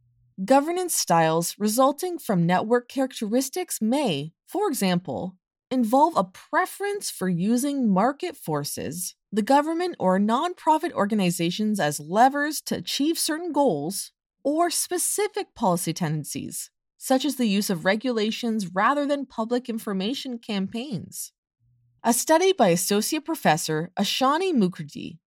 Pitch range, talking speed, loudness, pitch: 185-290 Hz, 115 wpm, -24 LUFS, 235 Hz